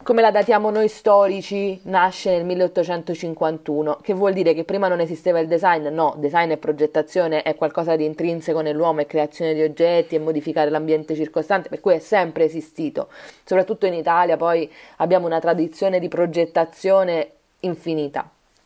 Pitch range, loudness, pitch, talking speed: 160-185 Hz, -20 LUFS, 170 Hz, 160 wpm